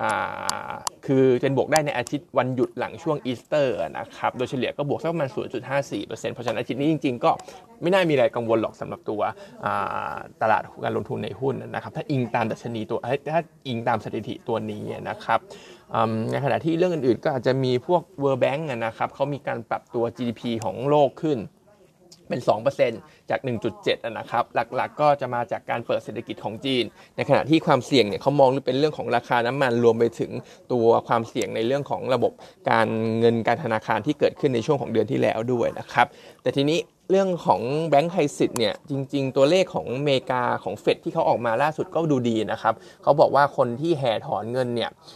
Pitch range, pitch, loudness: 120-155 Hz, 135 Hz, -24 LUFS